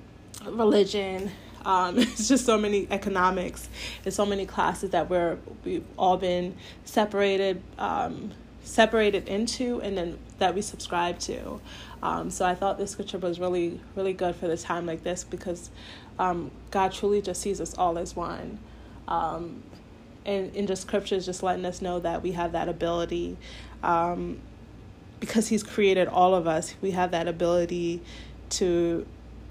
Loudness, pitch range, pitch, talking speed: -27 LUFS, 175-200 Hz, 185 Hz, 155 wpm